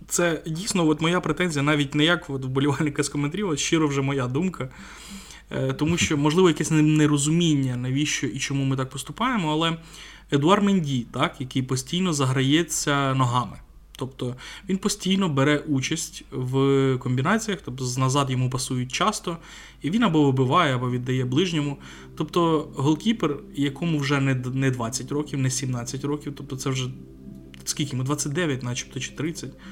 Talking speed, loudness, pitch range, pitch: 150 wpm, -24 LUFS, 130-165 Hz, 145 Hz